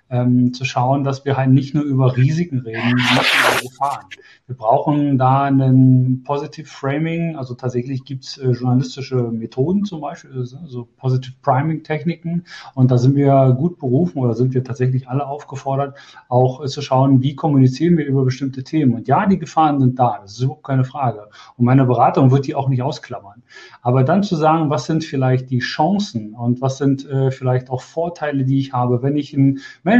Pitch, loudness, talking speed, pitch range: 135 Hz, -17 LUFS, 195 wpm, 125-145 Hz